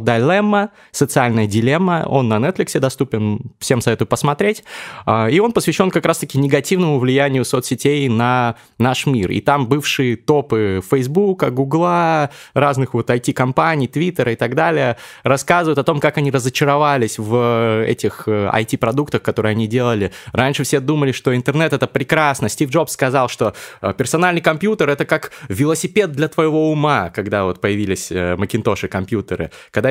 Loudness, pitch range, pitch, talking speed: -17 LUFS, 115-155 Hz, 135 Hz, 140 wpm